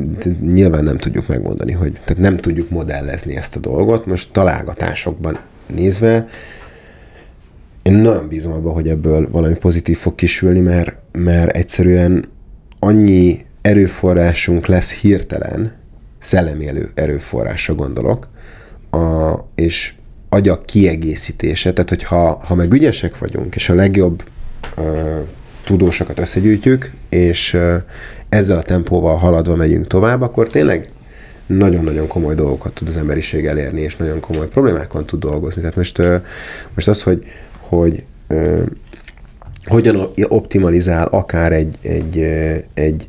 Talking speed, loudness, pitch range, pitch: 120 wpm, -15 LUFS, 80-95 Hz, 85 Hz